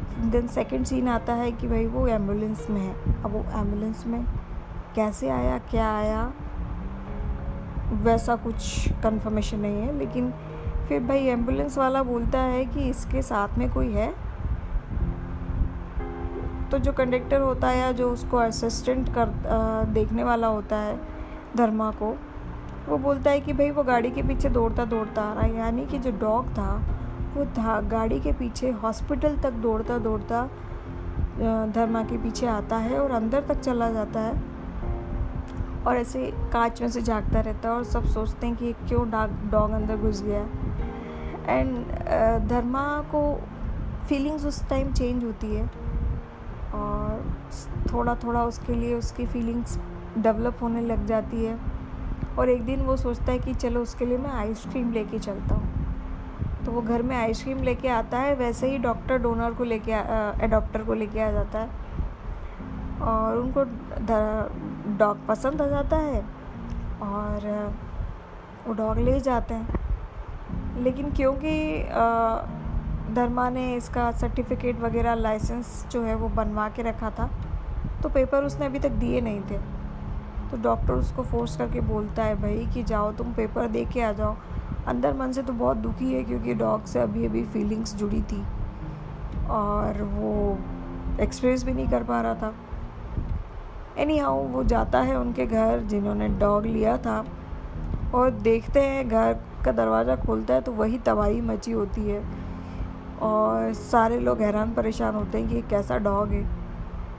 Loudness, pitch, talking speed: -27 LUFS, 225 Hz, 155 wpm